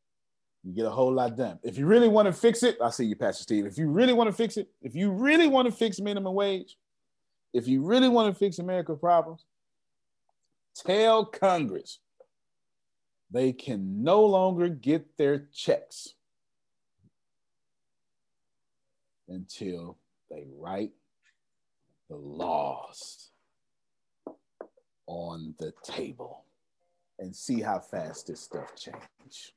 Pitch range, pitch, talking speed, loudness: 130-215 Hz, 175 Hz, 130 wpm, -26 LUFS